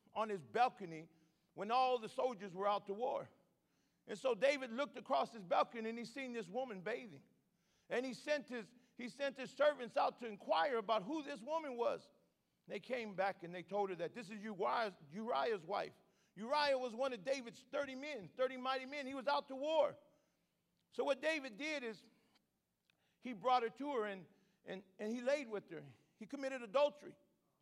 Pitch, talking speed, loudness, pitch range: 245 Hz, 190 wpm, -41 LUFS, 205-270 Hz